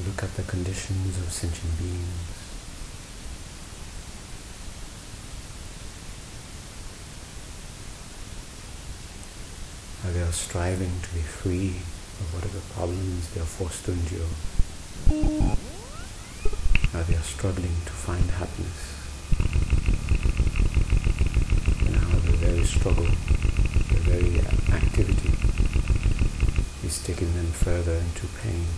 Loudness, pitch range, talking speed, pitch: -27 LUFS, 80-95 Hz, 90 wpm, 85 Hz